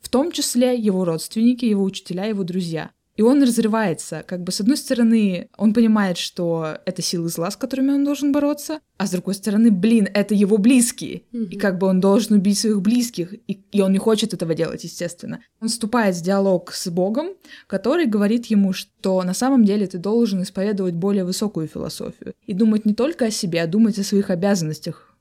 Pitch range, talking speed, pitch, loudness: 185-230 Hz, 195 wpm, 205 Hz, -20 LUFS